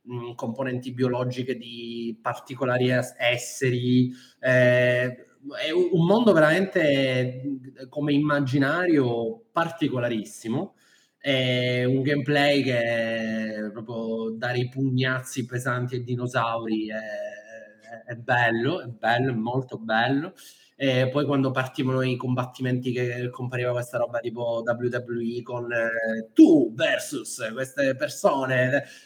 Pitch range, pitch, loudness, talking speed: 120-140 Hz, 125 Hz, -24 LUFS, 105 wpm